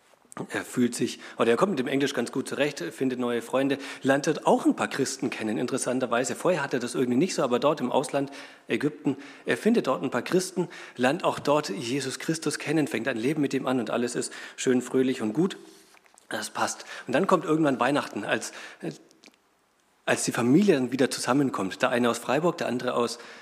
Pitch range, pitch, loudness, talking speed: 125-150 Hz, 135 Hz, -27 LUFS, 205 wpm